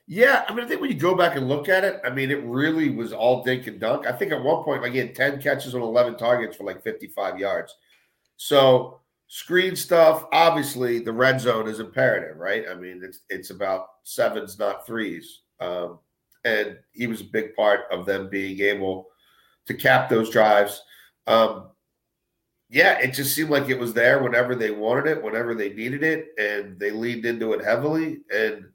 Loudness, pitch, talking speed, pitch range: -22 LUFS, 125 Hz, 200 wpm, 110-140 Hz